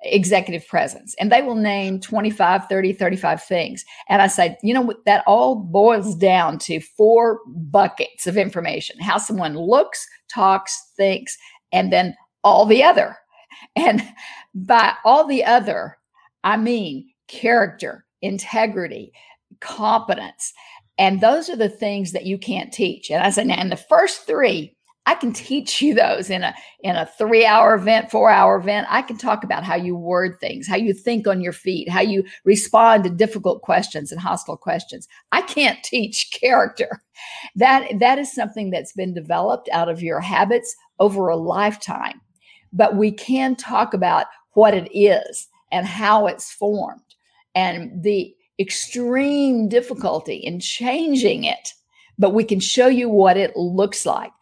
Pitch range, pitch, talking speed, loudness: 190-240 Hz, 210 Hz, 160 wpm, -18 LUFS